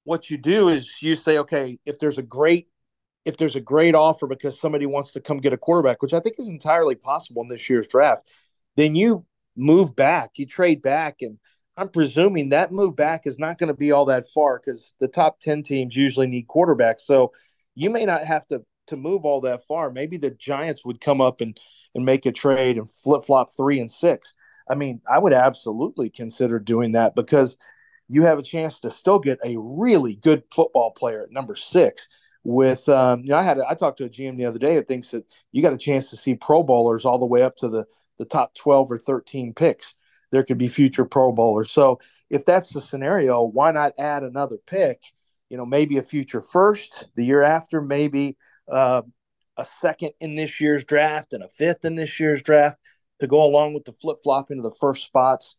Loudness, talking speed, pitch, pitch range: -20 LUFS, 220 wpm, 140 Hz, 130-155 Hz